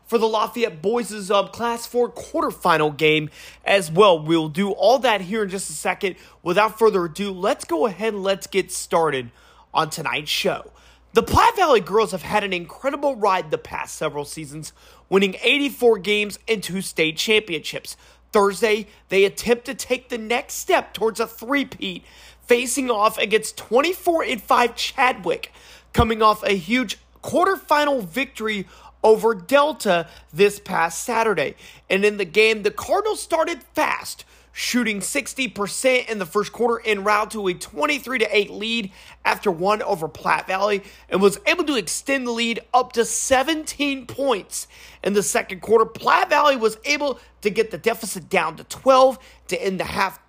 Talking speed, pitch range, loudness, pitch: 160 wpm, 195-250 Hz, -21 LUFS, 220 Hz